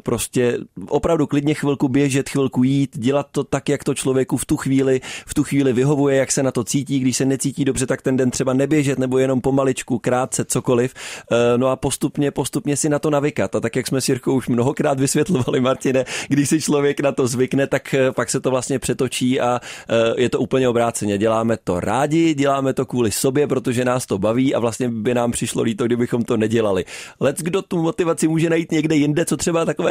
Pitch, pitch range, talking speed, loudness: 135 Hz, 125-145 Hz, 210 wpm, -19 LUFS